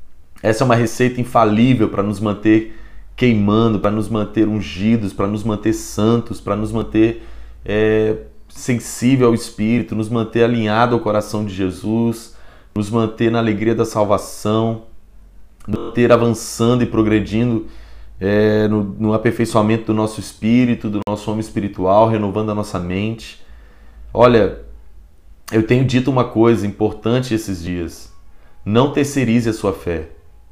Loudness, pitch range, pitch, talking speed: -17 LUFS, 100-115 Hz, 110 Hz, 140 wpm